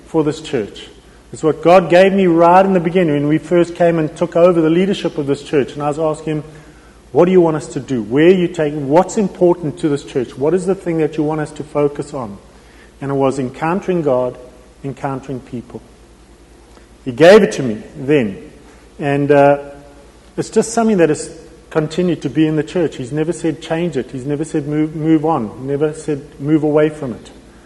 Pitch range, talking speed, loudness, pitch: 140-170 Hz, 215 wpm, -15 LUFS, 155 Hz